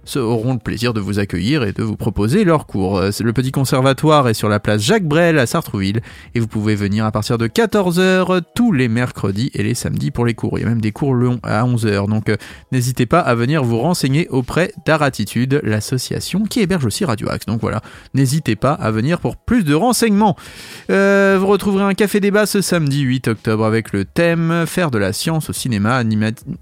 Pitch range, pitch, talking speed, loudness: 110-165 Hz, 130 Hz, 210 wpm, -17 LUFS